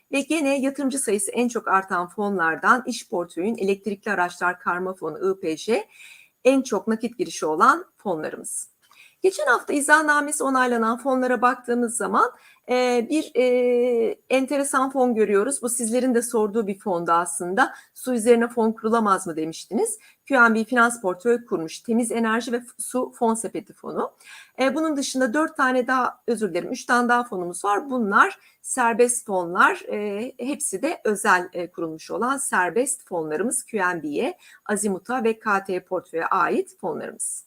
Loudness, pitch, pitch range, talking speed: -23 LUFS, 235 Hz, 200-260 Hz, 145 wpm